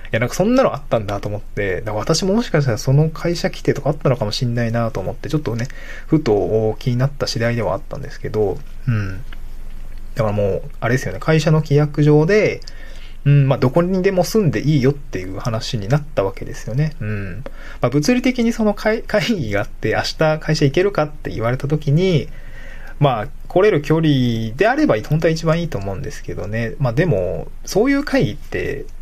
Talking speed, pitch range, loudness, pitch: 405 characters per minute, 115-160 Hz, -18 LUFS, 140 Hz